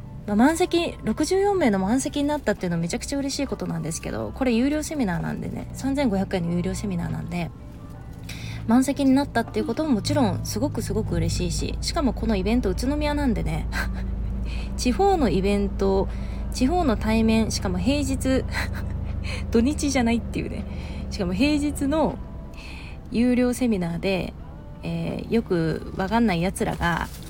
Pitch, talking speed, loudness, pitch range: 215 Hz, 340 characters per minute, -24 LUFS, 170-275 Hz